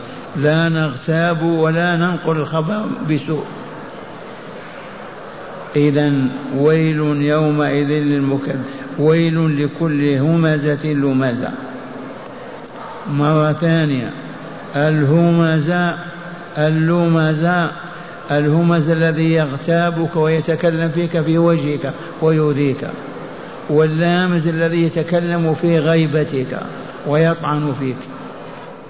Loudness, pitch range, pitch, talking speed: -17 LUFS, 150-170 Hz, 160 Hz, 70 wpm